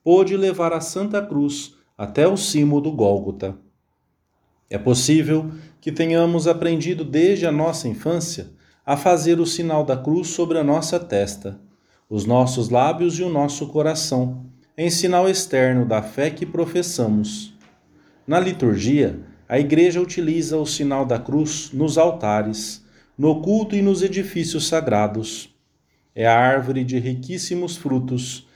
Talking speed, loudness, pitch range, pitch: 140 wpm, -20 LUFS, 125-170 Hz, 150 Hz